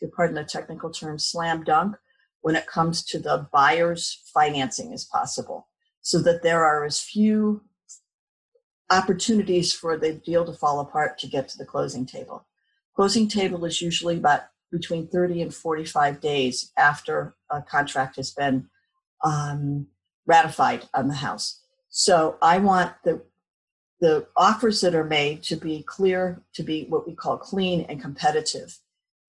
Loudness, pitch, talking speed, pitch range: -23 LUFS, 170 Hz, 150 wpm, 155-200 Hz